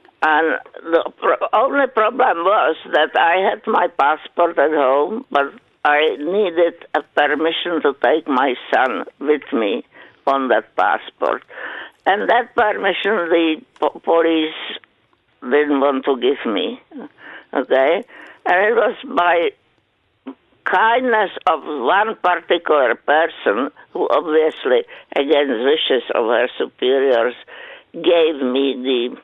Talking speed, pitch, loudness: 115 wpm, 170 Hz, -17 LUFS